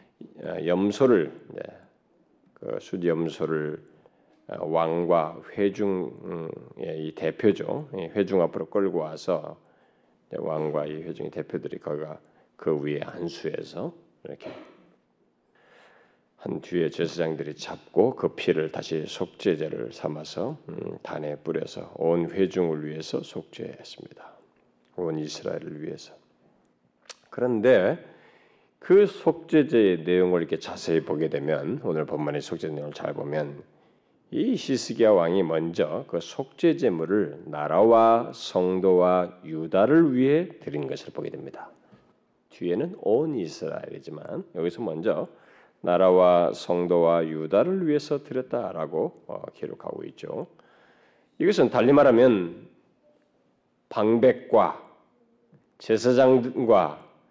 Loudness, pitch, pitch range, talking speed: -25 LUFS, 90 Hz, 80-125 Hz, 230 characters per minute